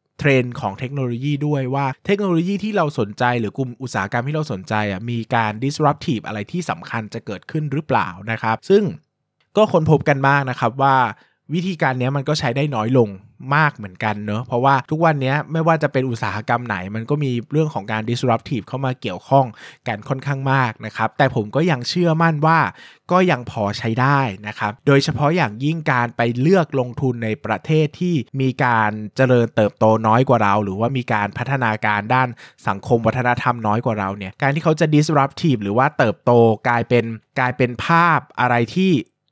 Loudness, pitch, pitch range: -19 LUFS, 130 Hz, 115-150 Hz